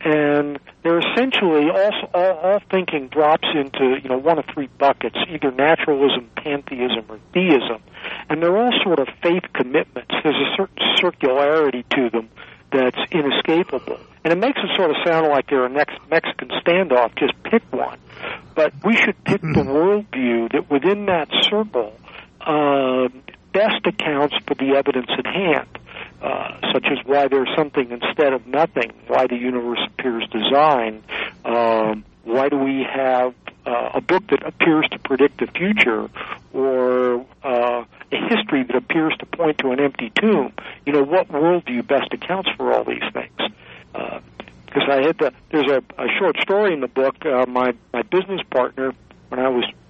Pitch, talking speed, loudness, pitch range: 140 Hz, 170 wpm, -19 LUFS, 125-170 Hz